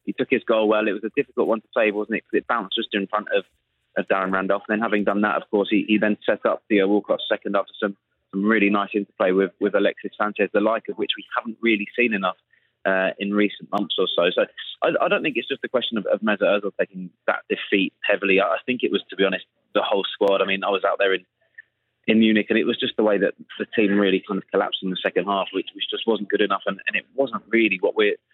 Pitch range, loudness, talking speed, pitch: 100-115 Hz, -22 LUFS, 275 wpm, 105 Hz